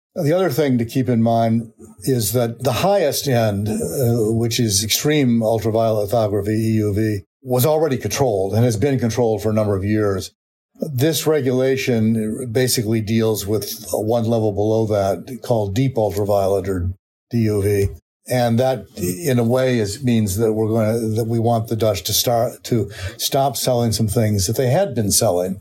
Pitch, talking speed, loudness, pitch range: 115 Hz, 170 wpm, -19 LUFS, 105-125 Hz